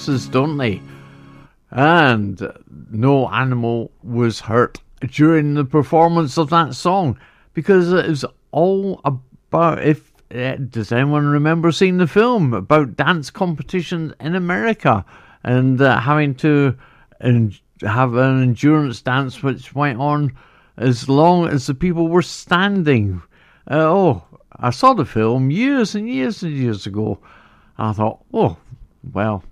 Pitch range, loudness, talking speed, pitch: 120-165 Hz, -17 LUFS, 130 wpm, 140 Hz